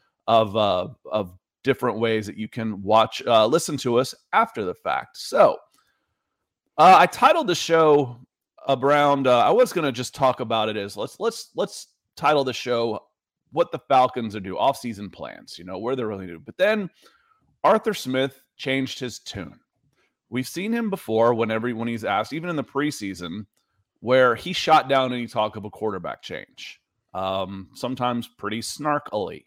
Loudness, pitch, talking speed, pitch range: -22 LUFS, 125 Hz, 175 wpm, 110-140 Hz